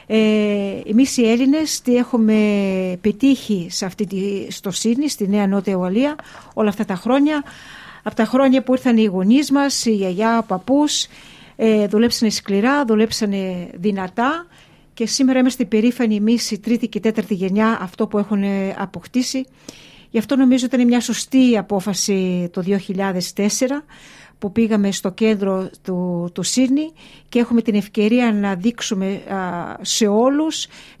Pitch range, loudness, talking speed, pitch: 200-245 Hz, -18 LUFS, 145 wpm, 220 Hz